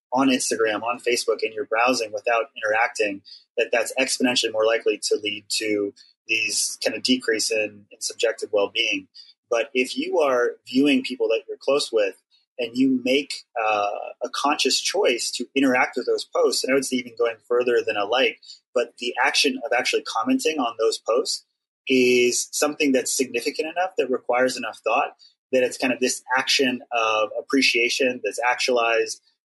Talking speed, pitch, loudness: 175 wpm, 150 Hz, -22 LUFS